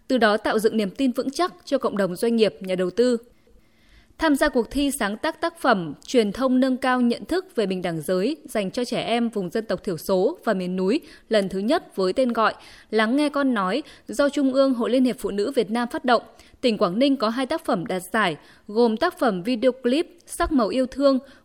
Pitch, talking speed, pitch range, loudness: 240 Hz, 240 wpm, 215-275 Hz, -23 LUFS